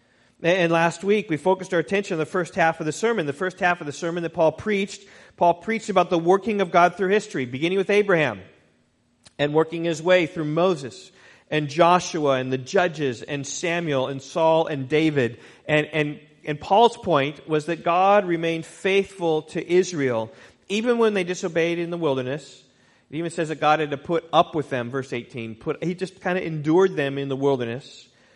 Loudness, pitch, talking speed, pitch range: -23 LUFS, 165 Hz, 200 wpm, 140-180 Hz